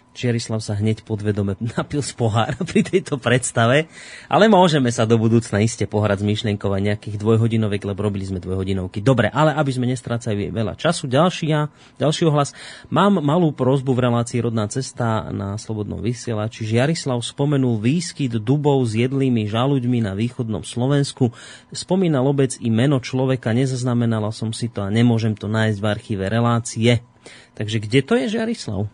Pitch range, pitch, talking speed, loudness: 110-140 Hz, 120 Hz, 165 wpm, -20 LUFS